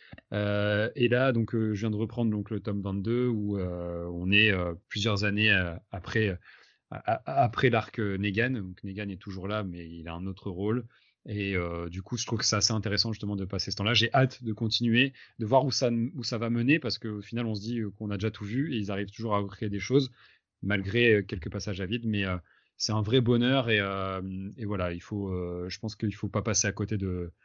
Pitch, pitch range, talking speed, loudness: 105 Hz, 100-115 Hz, 240 wpm, -29 LUFS